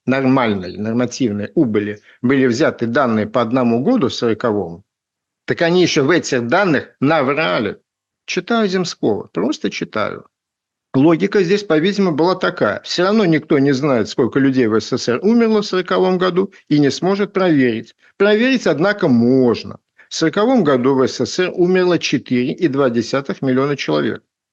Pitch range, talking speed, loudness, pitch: 120-185 Hz, 135 wpm, -16 LUFS, 140 Hz